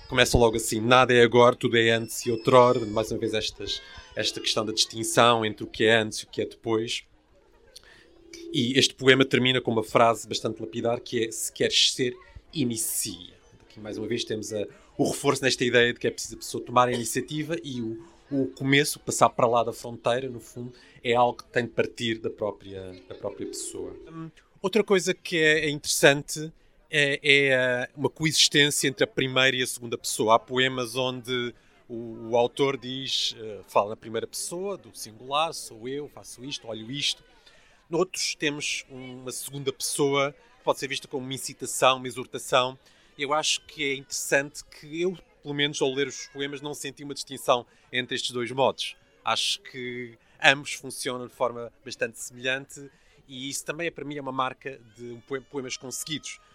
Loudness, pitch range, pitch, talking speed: -25 LUFS, 120-145 Hz, 130 Hz, 185 wpm